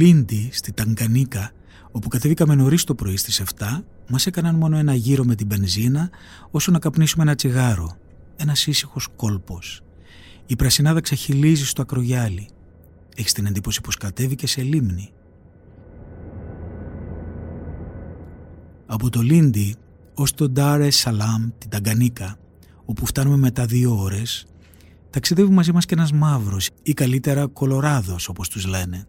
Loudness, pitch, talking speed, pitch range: -20 LUFS, 115 Hz, 130 wpm, 90-140 Hz